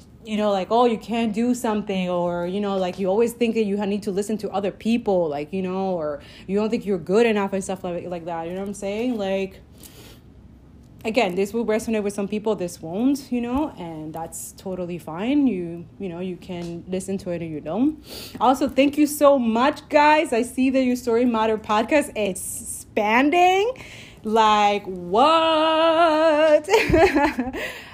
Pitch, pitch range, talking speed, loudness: 215 Hz, 190-255 Hz, 185 wpm, -21 LUFS